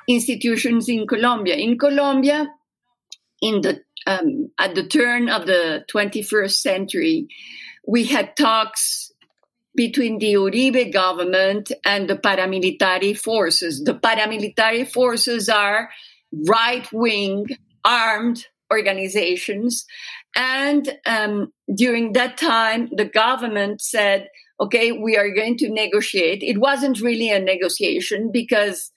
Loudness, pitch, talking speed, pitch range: -19 LUFS, 230 Hz, 115 wpm, 205-255 Hz